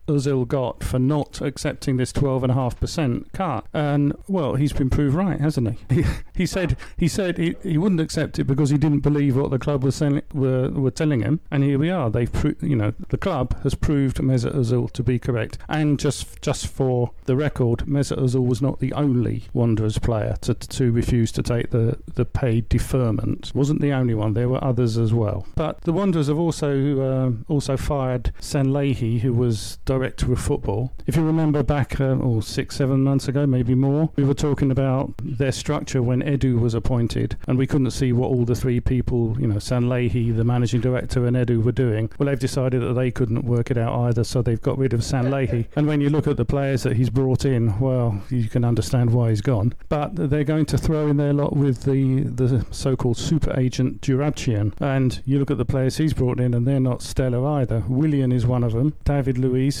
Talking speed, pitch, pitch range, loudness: 215 wpm, 130 Hz, 120-145 Hz, -22 LUFS